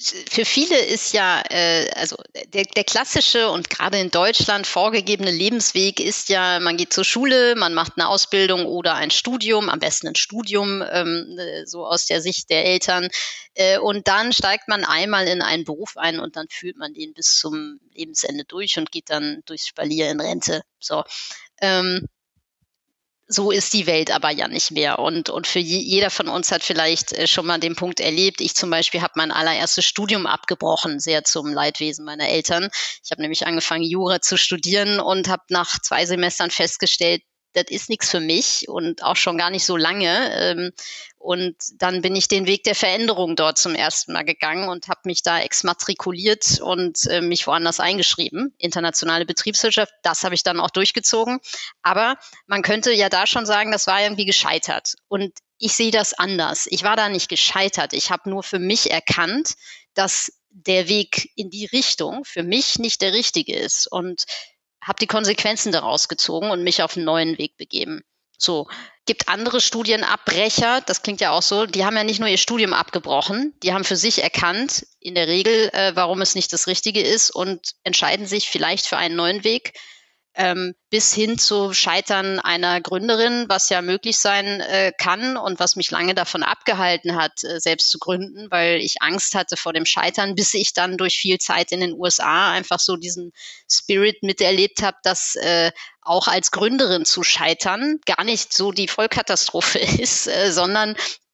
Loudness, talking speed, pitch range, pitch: -19 LUFS, 180 wpm, 175-210 Hz, 185 Hz